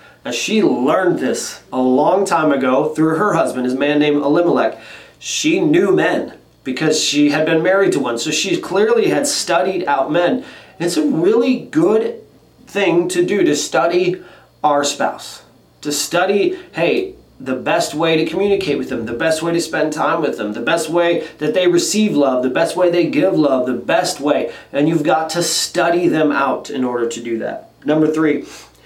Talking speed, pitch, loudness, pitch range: 190 wpm, 160 Hz, -16 LUFS, 145-215 Hz